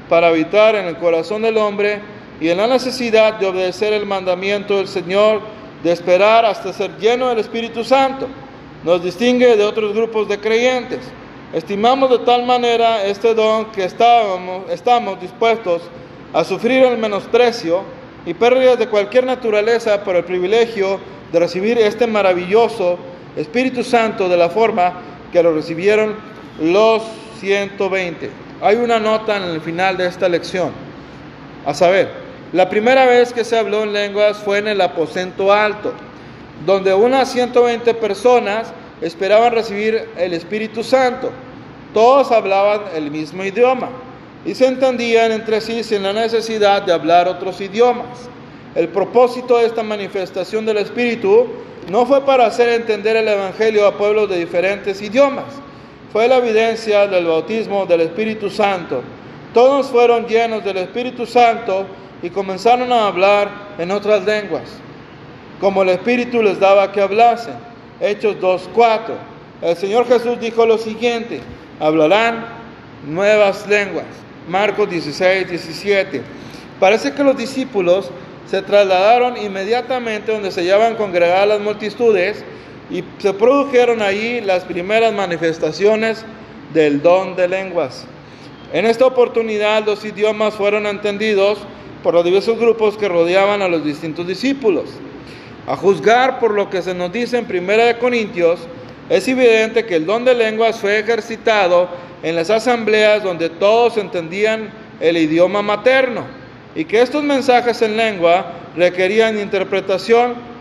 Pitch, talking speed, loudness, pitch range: 210 Hz, 140 wpm, -15 LUFS, 185-230 Hz